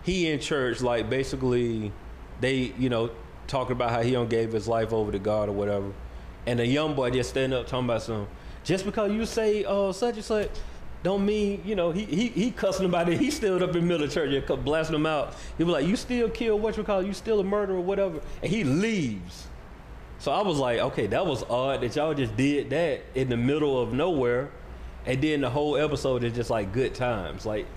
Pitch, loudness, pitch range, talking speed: 135 Hz, -27 LUFS, 120-190 Hz, 235 wpm